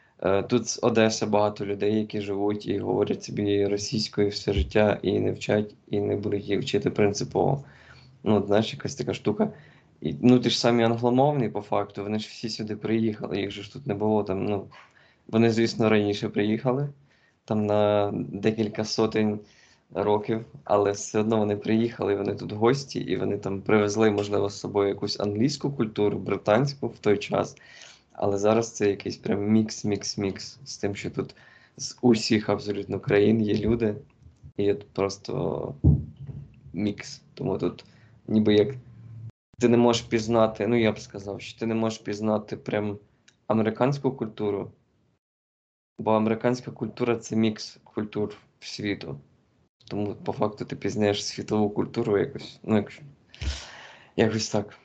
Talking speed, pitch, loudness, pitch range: 155 wpm, 105 Hz, -26 LUFS, 100-115 Hz